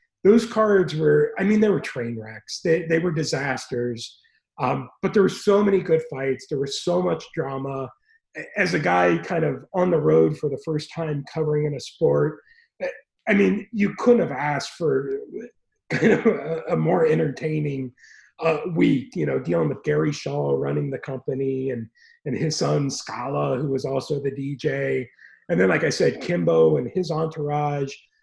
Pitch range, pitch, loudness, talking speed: 135-195 Hz, 150 Hz, -23 LUFS, 180 wpm